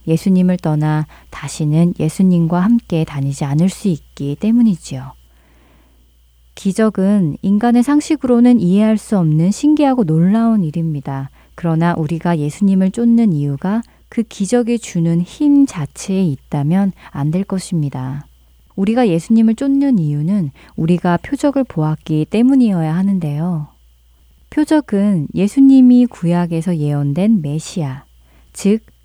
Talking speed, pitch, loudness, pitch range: 285 characters per minute, 175 Hz, -15 LUFS, 150-220 Hz